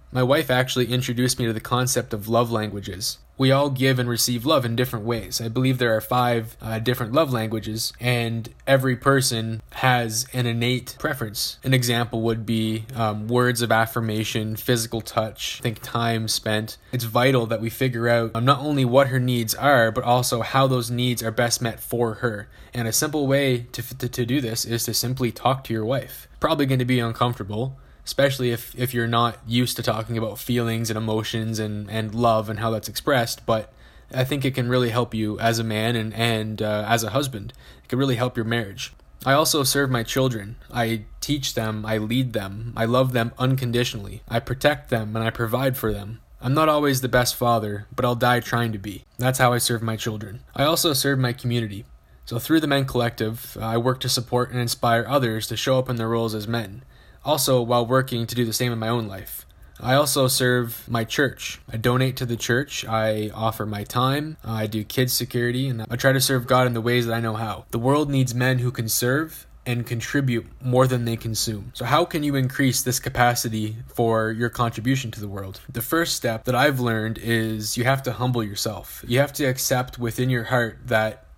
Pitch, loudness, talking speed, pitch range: 120 Hz, -23 LUFS, 215 wpm, 115-125 Hz